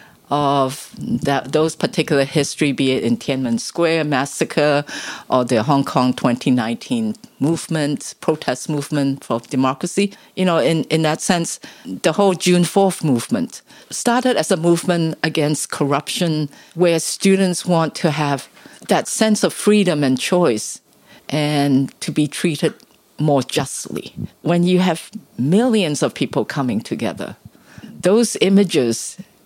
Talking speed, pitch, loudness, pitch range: 130 wpm, 160 Hz, -18 LUFS, 140-180 Hz